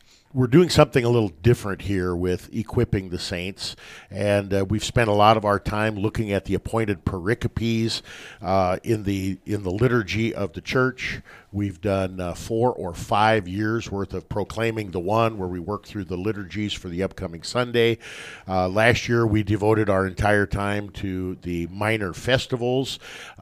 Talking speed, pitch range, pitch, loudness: 175 wpm, 95-115 Hz, 105 Hz, -23 LUFS